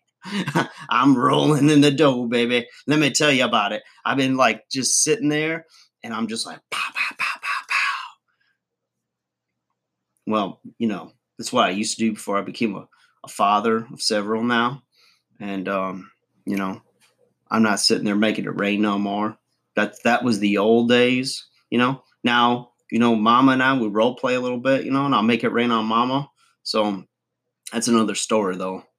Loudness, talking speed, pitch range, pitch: -21 LUFS, 190 wpm, 105-135 Hz, 120 Hz